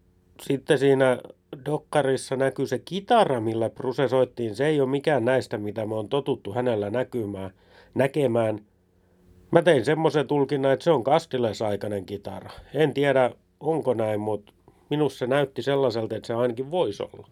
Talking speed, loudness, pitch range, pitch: 150 wpm, -25 LUFS, 110-140 Hz, 130 Hz